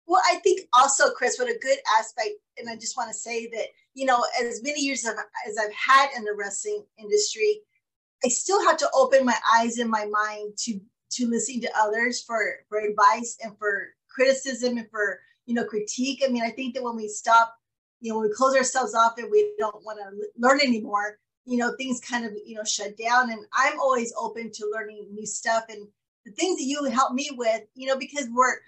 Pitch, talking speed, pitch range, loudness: 235 Hz, 220 wpm, 215-265 Hz, -24 LUFS